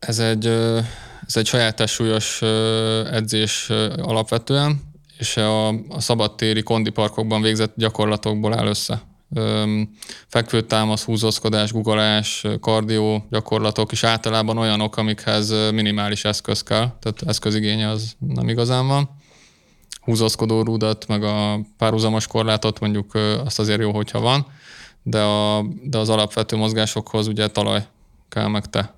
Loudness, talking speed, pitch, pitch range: -20 LUFS, 120 wpm, 110 Hz, 105-115 Hz